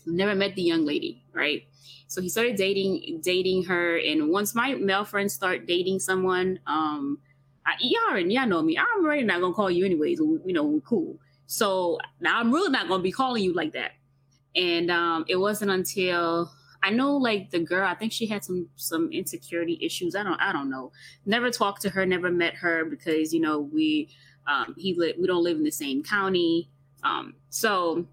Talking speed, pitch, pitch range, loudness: 205 wpm, 185 Hz, 170-230 Hz, -26 LUFS